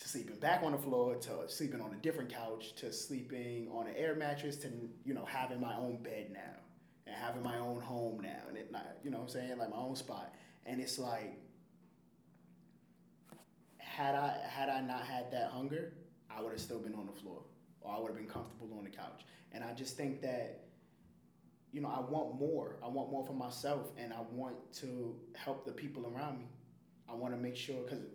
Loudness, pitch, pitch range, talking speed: -42 LUFS, 125 Hz, 115-135 Hz, 215 wpm